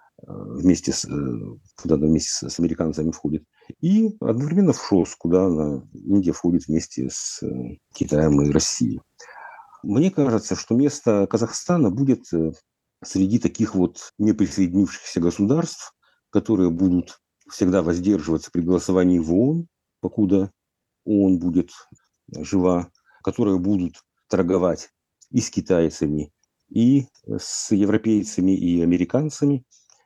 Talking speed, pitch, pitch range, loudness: 110 wpm, 95 Hz, 85-115 Hz, -21 LUFS